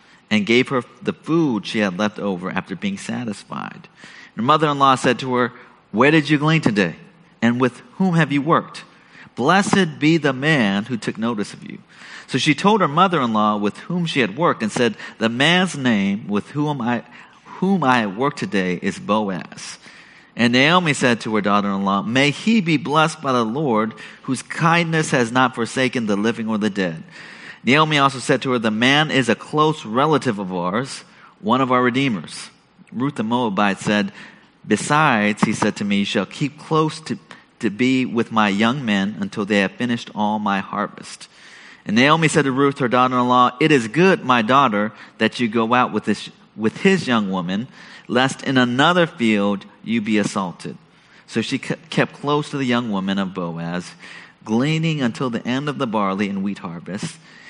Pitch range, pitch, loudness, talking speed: 110-155 Hz, 130 Hz, -19 LUFS, 185 wpm